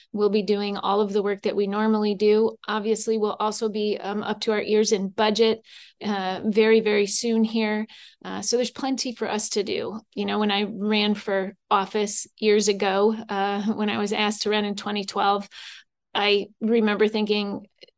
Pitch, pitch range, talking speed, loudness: 210 Hz, 205-220 Hz, 185 wpm, -23 LUFS